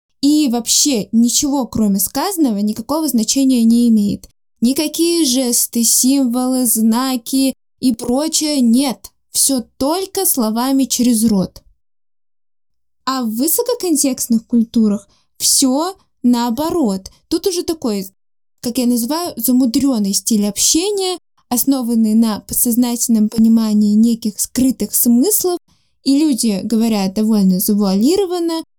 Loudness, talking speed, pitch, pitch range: -15 LUFS, 100 wpm, 245 Hz, 225-285 Hz